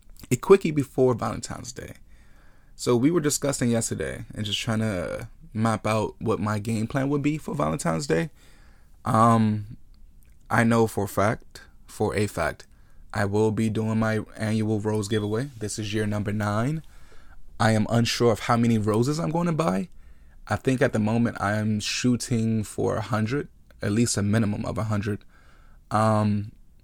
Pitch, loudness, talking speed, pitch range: 110 Hz, -25 LUFS, 170 wpm, 105-120 Hz